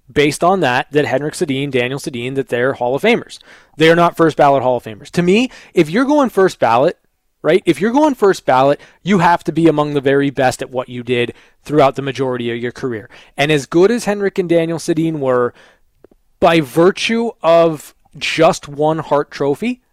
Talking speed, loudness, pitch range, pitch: 200 wpm, -15 LUFS, 130-175 Hz, 150 Hz